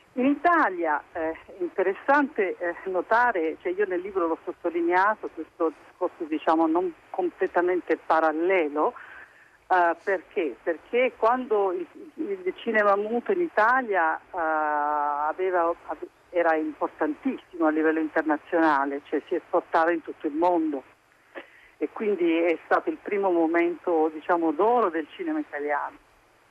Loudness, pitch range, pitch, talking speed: -25 LUFS, 160-235 Hz, 175 Hz, 125 wpm